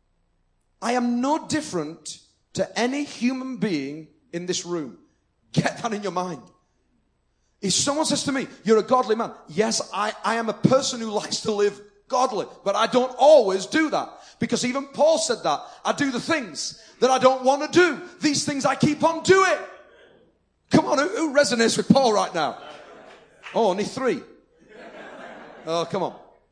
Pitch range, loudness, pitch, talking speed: 195-285 Hz, -23 LUFS, 235 Hz, 175 wpm